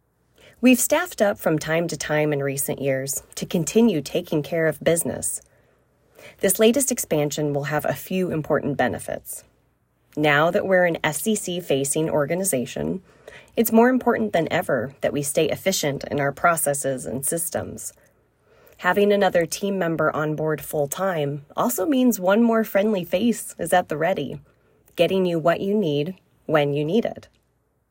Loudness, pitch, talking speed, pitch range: -22 LUFS, 170 Hz, 155 wpm, 145-205 Hz